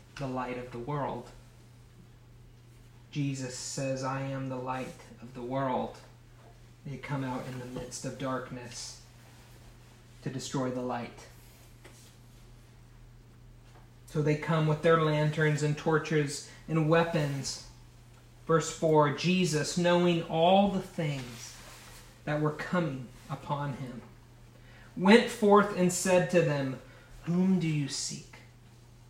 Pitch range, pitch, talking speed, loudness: 120-150 Hz, 125 Hz, 120 wpm, -30 LUFS